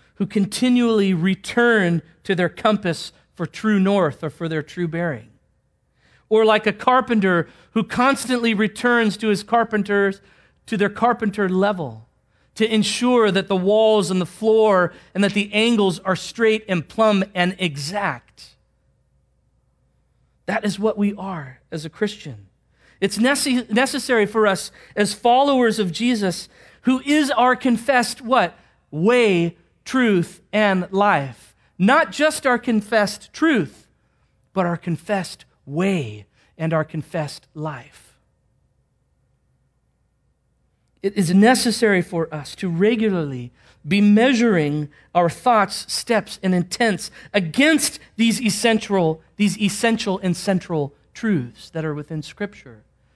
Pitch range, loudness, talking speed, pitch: 170-225 Hz, -20 LUFS, 125 wpm, 200 Hz